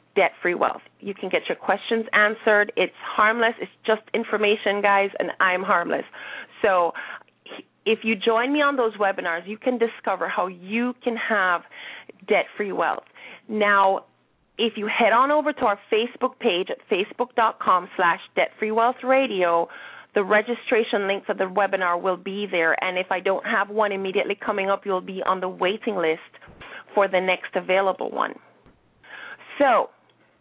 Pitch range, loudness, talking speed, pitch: 190-225 Hz, -23 LUFS, 165 wpm, 210 Hz